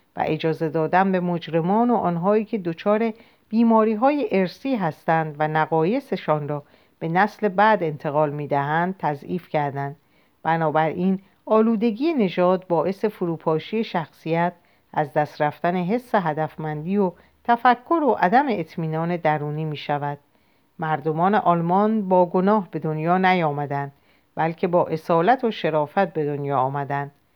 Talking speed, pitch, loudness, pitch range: 125 wpm, 170 Hz, -22 LUFS, 155-205 Hz